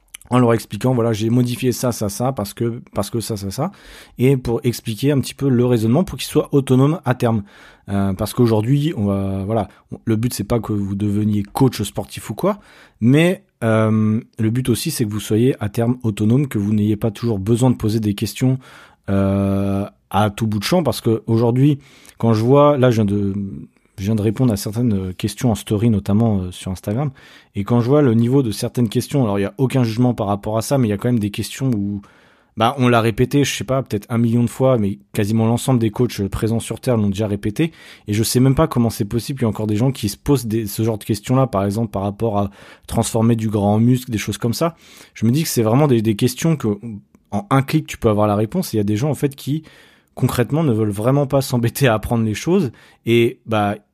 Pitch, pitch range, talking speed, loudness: 115 Hz, 105-130 Hz, 250 wpm, -18 LUFS